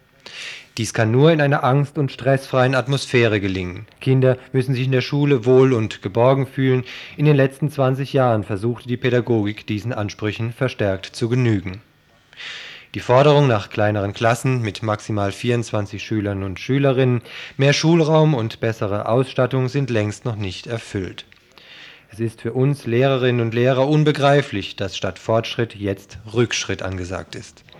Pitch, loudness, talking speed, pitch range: 120 Hz, -19 LUFS, 150 wpm, 105-135 Hz